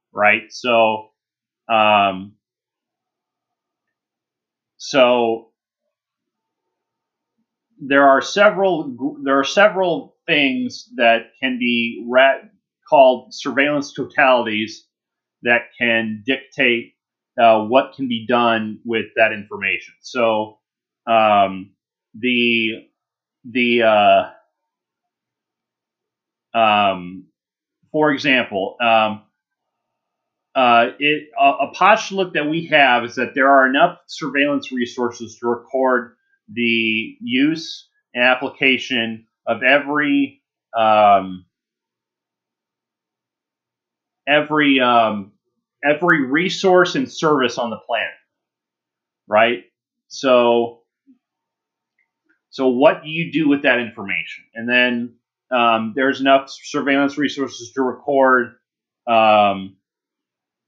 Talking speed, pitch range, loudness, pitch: 90 wpm, 115-155 Hz, -17 LUFS, 130 Hz